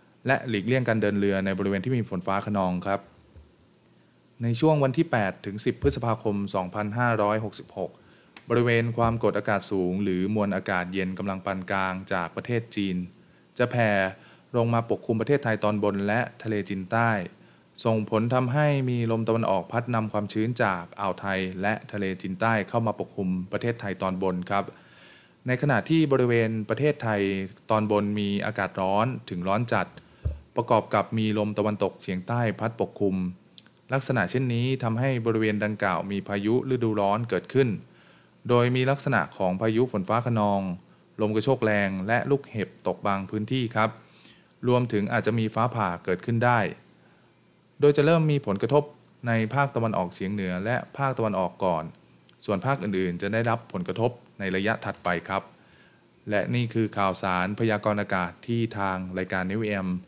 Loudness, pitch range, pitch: -26 LUFS, 95-115 Hz, 105 Hz